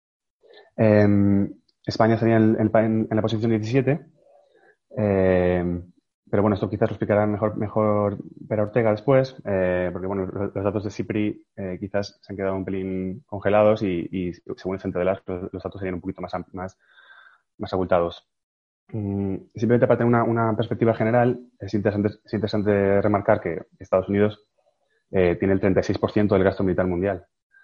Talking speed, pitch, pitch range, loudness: 175 wpm, 105 Hz, 95-110 Hz, -23 LUFS